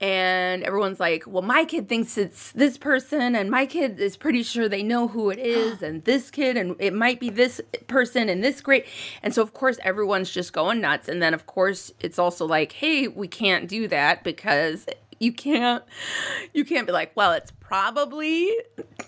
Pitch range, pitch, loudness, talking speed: 195-275 Hz, 235 Hz, -23 LUFS, 200 wpm